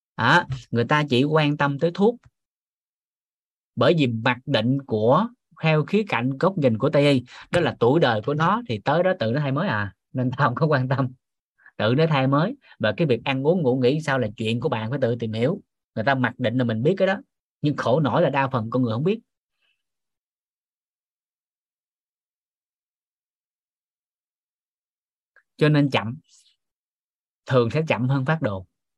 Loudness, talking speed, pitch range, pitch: -22 LUFS, 185 wpm, 125-160 Hz, 135 Hz